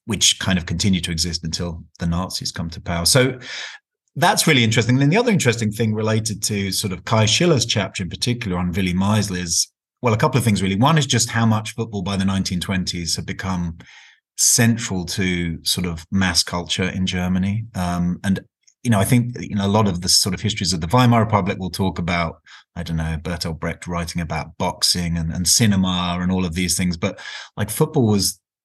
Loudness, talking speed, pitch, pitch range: -19 LUFS, 215 wpm, 95 Hz, 90-110 Hz